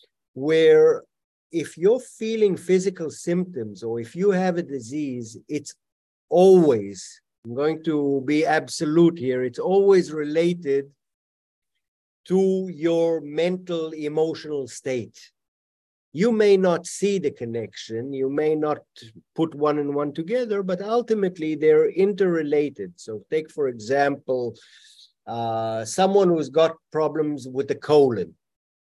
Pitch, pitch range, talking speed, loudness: 155 Hz, 135-185 Hz, 120 wpm, -22 LUFS